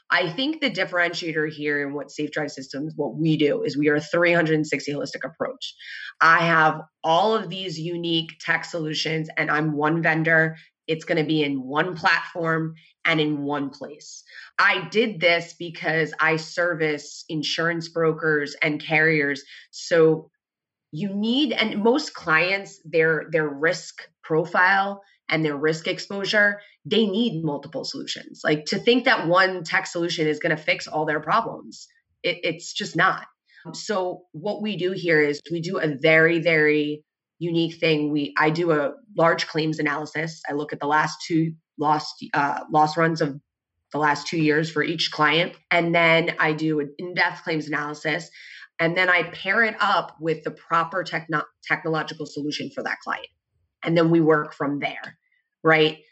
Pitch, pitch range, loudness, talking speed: 160 Hz, 150-175 Hz, -22 LUFS, 170 wpm